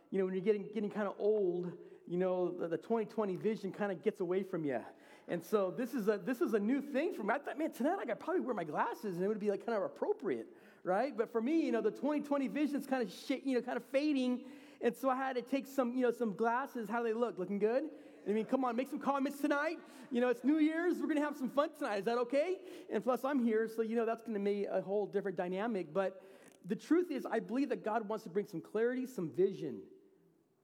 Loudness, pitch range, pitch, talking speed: -36 LUFS, 205-275 Hz, 235 Hz, 265 wpm